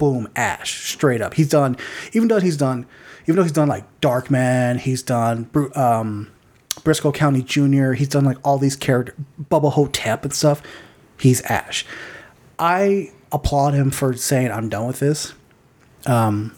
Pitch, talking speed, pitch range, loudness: 135 Hz, 165 wpm, 125-145 Hz, -19 LUFS